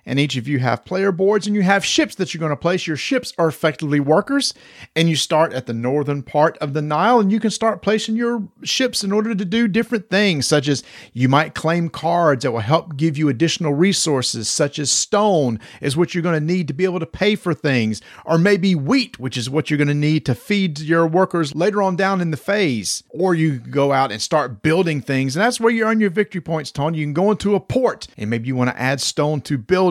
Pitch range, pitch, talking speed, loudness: 145-195 Hz, 160 Hz, 250 wpm, -19 LUFS